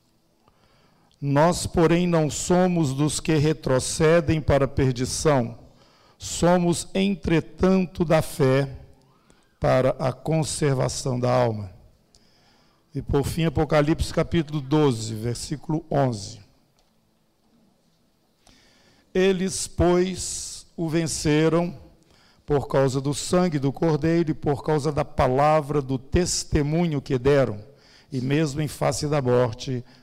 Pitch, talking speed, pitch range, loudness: 150 Hz, 105 wpm, 130-165 Hz, -23 LUFS